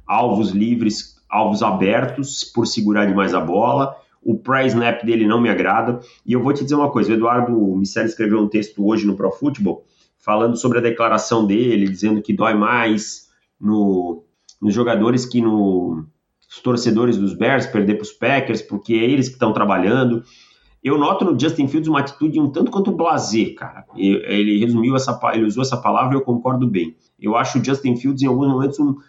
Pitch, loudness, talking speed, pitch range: 115 Hz, -18 LUFS, 190 wpm, 105-130 Hz